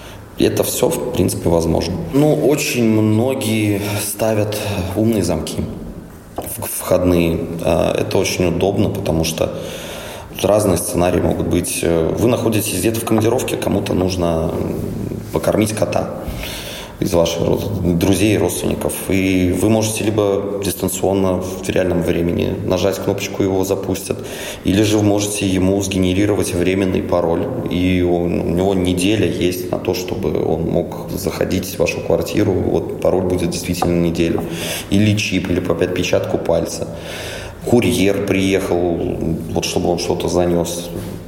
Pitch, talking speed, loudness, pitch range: 90 Hz, 135 wpm, -18 LUFS, 85-100 Hz